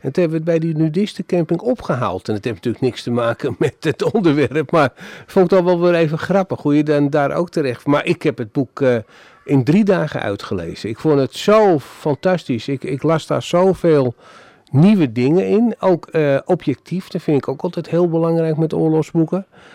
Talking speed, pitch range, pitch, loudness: 205 wpm, 135-180 Hz, 155 Hz, -17 LUFS